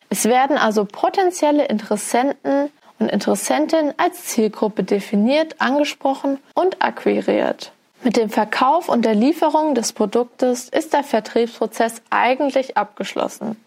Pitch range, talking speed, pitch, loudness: 220-290 Hz, 115 wpm, 250 Hz, -19 LUFS